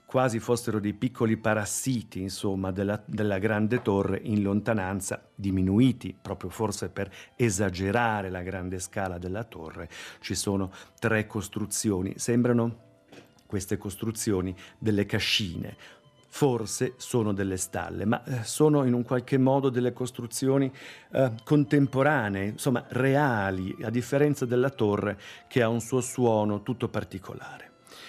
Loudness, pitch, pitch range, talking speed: -28 LUFS, 110 Hz, 100-125 Hz, 125 wpm